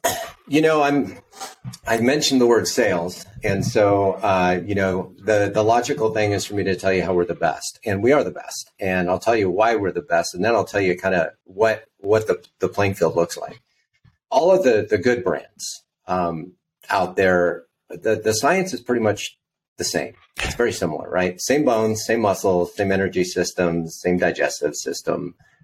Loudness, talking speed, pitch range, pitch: -20 LUFS, 200 wpm, 90-110 Hz, 100 Hz